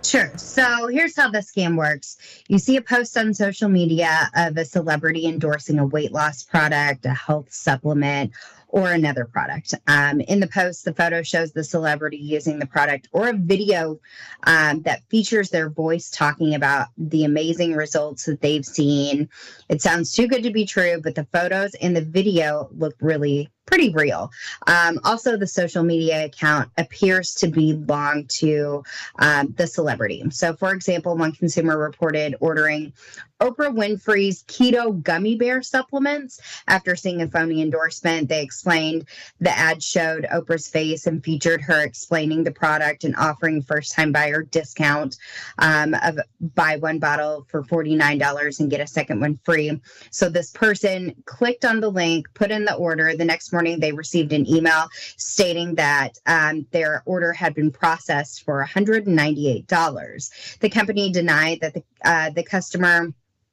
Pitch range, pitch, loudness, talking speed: 150-180 Hz, 160 Hz, -20 LUFS, 160 wpm